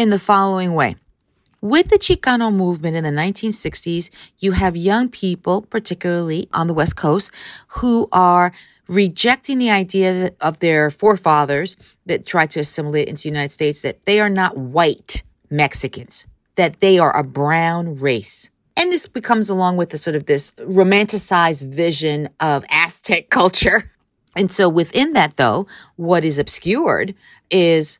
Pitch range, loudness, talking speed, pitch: 155-200 Hz, -17 LUFS, 150 wpm, 175 Hz